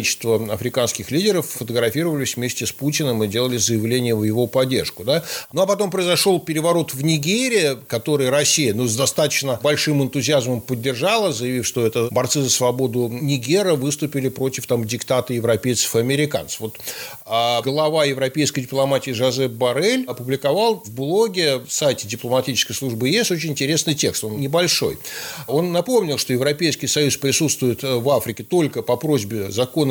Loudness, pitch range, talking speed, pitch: -20 LUFS, 120-150 Hz, 150 wpm, 135 Hz